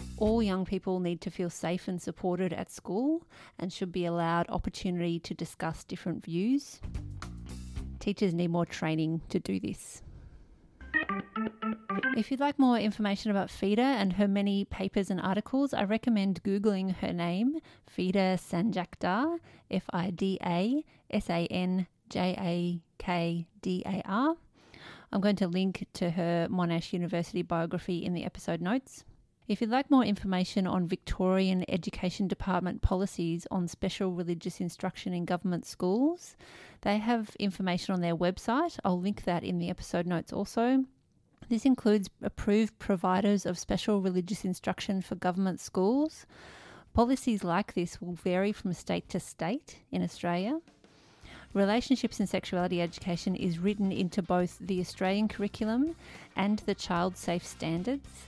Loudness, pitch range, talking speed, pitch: -31 LUFS, 175-210 Hz, 145 wpm, 190 Hz